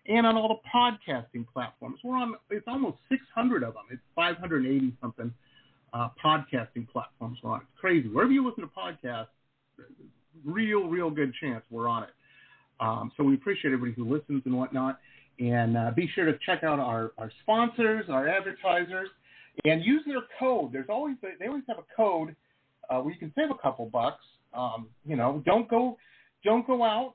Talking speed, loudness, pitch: 190 wpm, -29 LUFS, 155 Hz